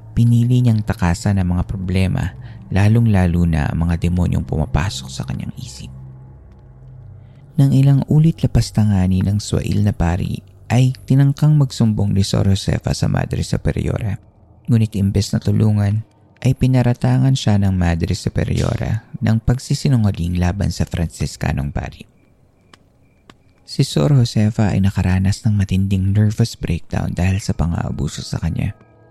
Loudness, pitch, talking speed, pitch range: -18 LUFS, 105 Hz, 130 wpm, 95-120 Hz